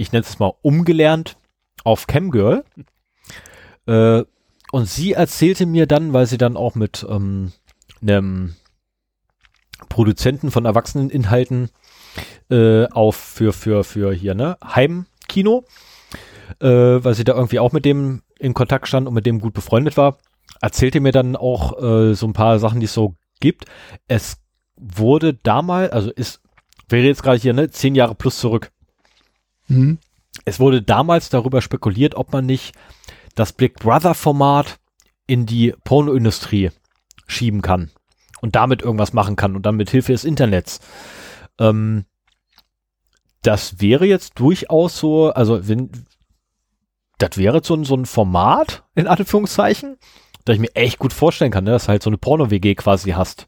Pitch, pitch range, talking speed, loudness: 120 Hz, 105-140 Hz, 155 wpm, -17 LUFS